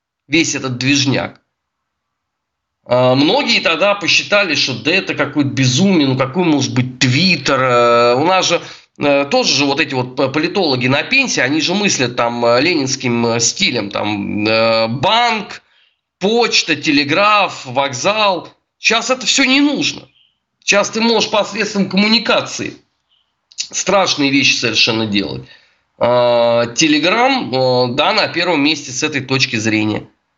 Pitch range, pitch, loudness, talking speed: 125-195 Hz, 145 Hz, -14 LUFS, 120 wpm